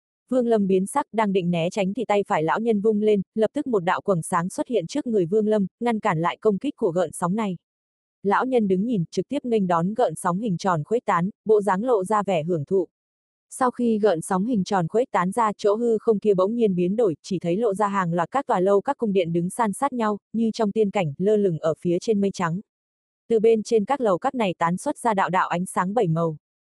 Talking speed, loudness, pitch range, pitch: 265 wpm, -23 LUFS, 180-225 Hz, 205 Hz